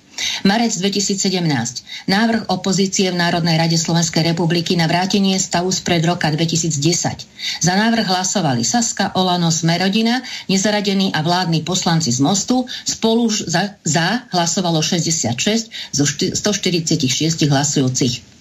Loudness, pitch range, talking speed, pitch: -17 LUFS, 165-200 Hz, 115 wpm, 180 Hz